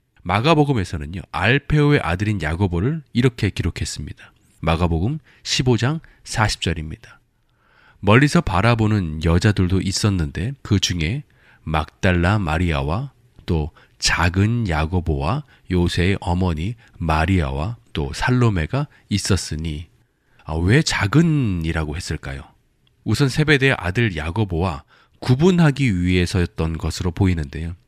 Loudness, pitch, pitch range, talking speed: -20 LUFS, 95 Hz, 85-120 Hz, 275 characters per minute